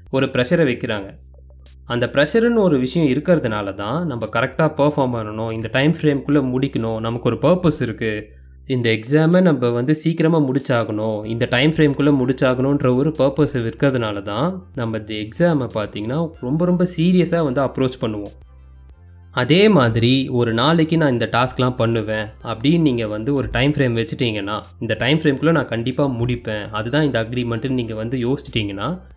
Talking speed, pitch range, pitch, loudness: 150 wpm, 110-150 Hz, 125 Hz, -19 LUFS